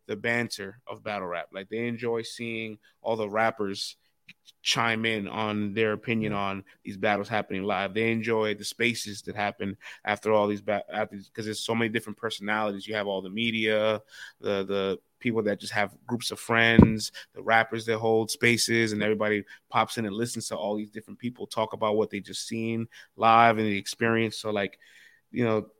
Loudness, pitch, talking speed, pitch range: -27 LUFS, 110 Hz, 190 wpm, 105-115 Hz